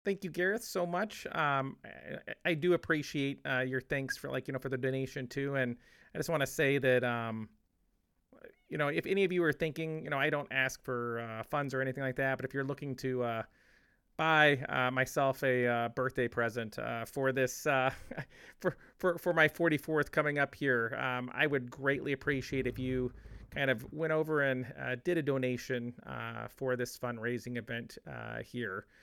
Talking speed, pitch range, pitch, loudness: 200 wpm, 125-150 Hz, 135 Hz, -33 LUFS